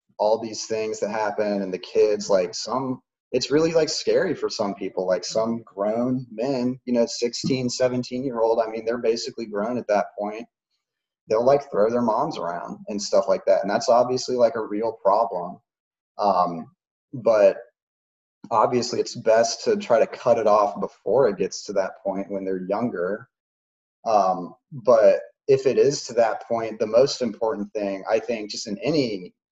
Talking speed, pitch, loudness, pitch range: 180 wpm, 115 Hz, -23 LUFS, 100-125 Hz